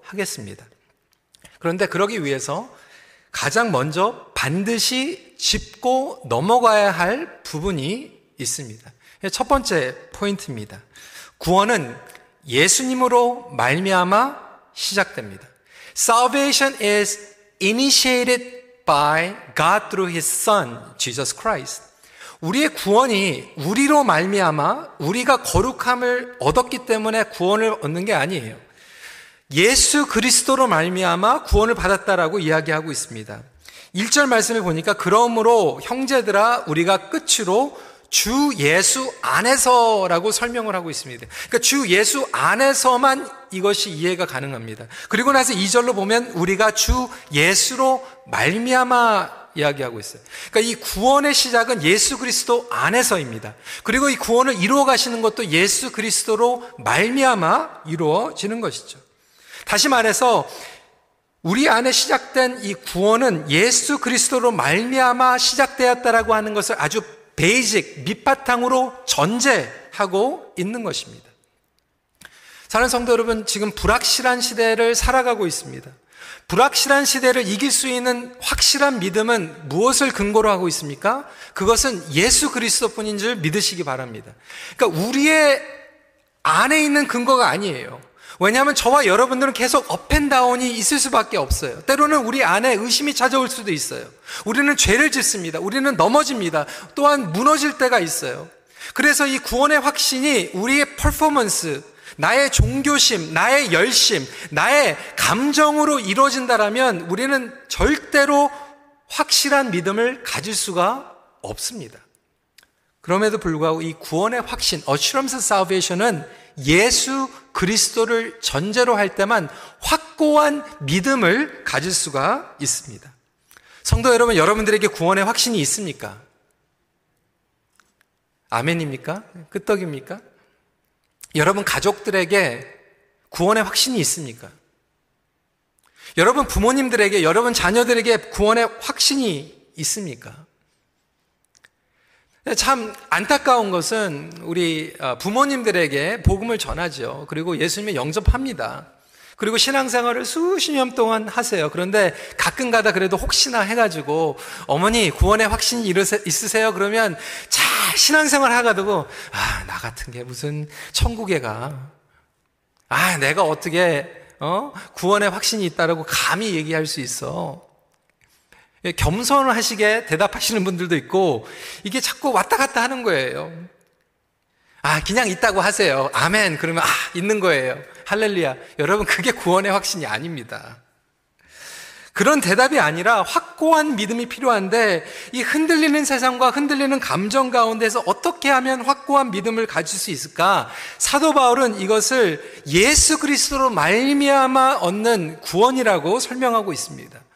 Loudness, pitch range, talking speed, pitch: -18 LUFS, 185-260 Hz, 305 characters per minute, 225 Hz